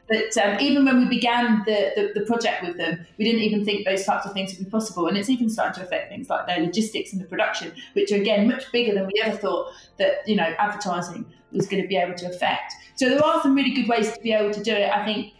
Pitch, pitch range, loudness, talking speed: 210 Hz, 195-235 Hz, -23 LUFS, 275 wpm